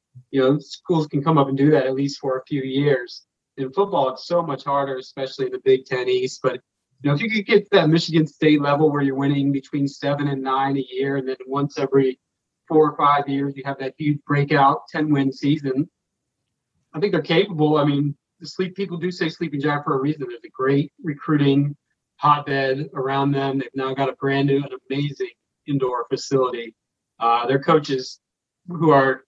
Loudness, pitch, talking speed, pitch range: -21 LUFS, 140 Hz, 205 wpm, 135-155 Hz